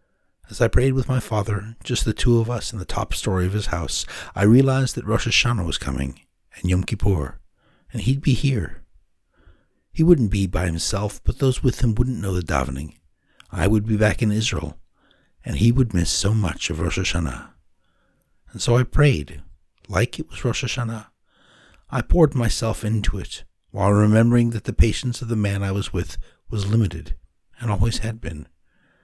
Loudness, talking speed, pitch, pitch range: -22 LUFS, 190 wpm, 105 Hz, 90-120 Hz